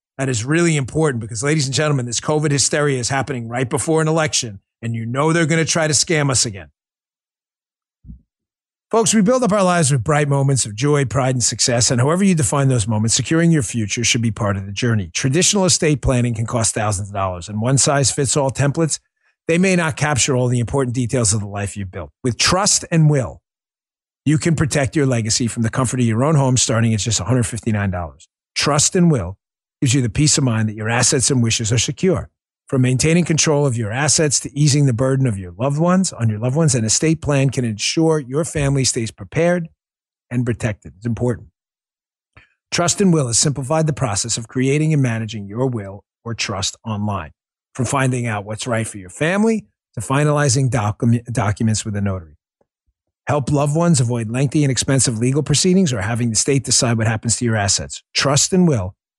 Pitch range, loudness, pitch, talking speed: 115-150 Hz, -17 LUFS, 130 Hz, 205 wpm